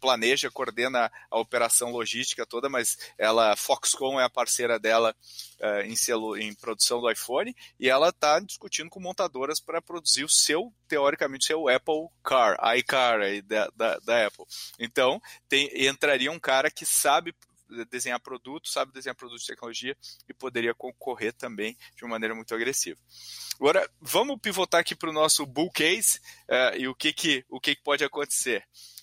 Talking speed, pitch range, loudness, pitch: 170 wpm, 115-155 Hz, -26 LUFS, 130 Hz